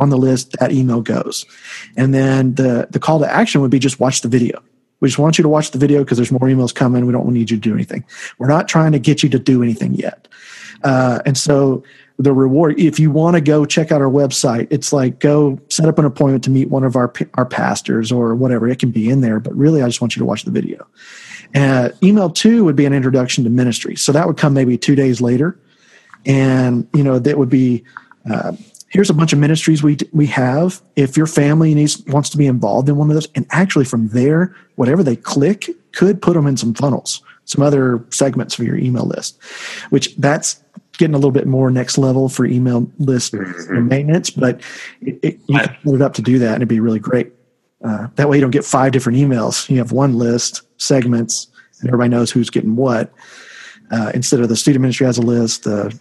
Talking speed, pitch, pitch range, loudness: 240 wpm, 135 Hz, 125-150 Hz, -15 LUFS